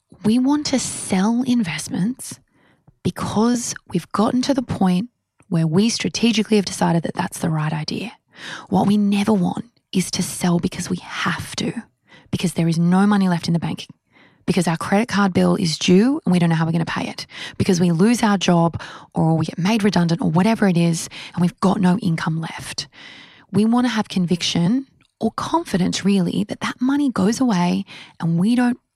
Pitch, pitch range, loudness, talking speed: 190 Hz, 170-220 Hz, -20 LUFS, 195 wpm